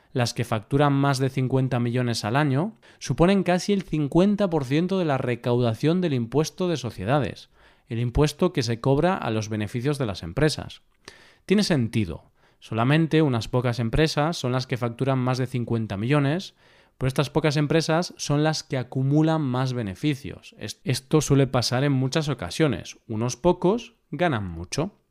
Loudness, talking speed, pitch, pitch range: -24 LUFS, 155 wpm, 140 Hz, 120-155 Hz